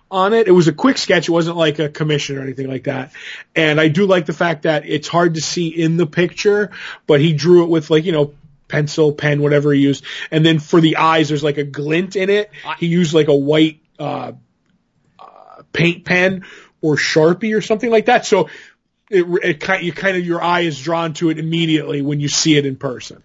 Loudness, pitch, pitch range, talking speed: -16 LUFS, 160 Hz, 150-175 Hz, 230 wpm